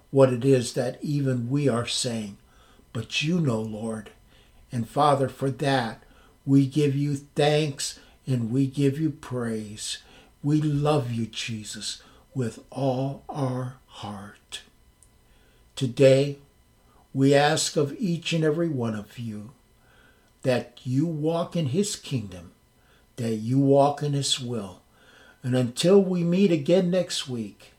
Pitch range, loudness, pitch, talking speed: 115-145 Hz, -25 LUFS, 135 Hz, 135 wpm